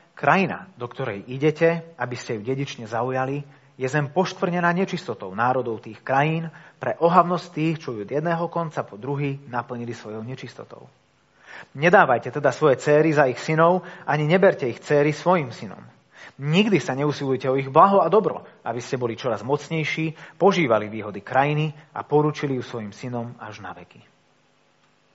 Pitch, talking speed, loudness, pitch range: 140 Hz, 160 wpm, -22 LUFS, 125-160 Hz